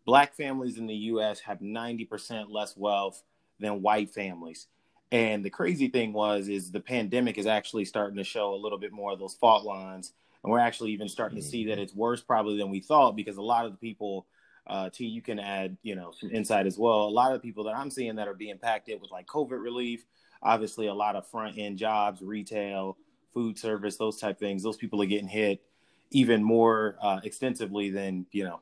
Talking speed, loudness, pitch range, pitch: 225 wpm, -29 LUFS, 100-115 Hz, 105 Hz